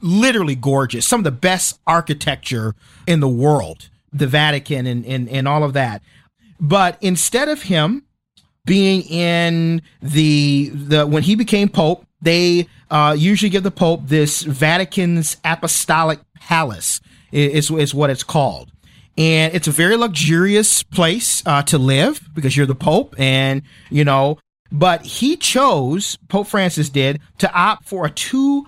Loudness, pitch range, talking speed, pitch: -16 LUFS, 145-185 Hz, 150 wpm, 160 Hz